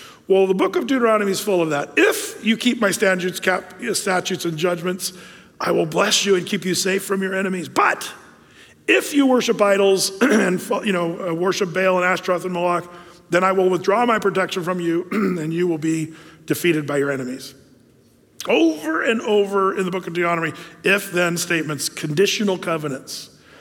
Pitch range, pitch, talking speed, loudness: 170-195 Hz, 185 Hz, 180 wpm, -20 LUFS